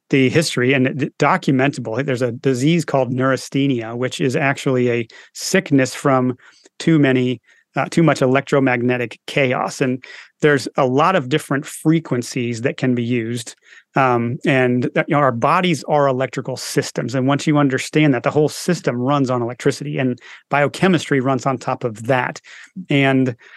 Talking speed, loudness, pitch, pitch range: 155 wpm, -18 LUFS, 135 Hz, 125-145 Hz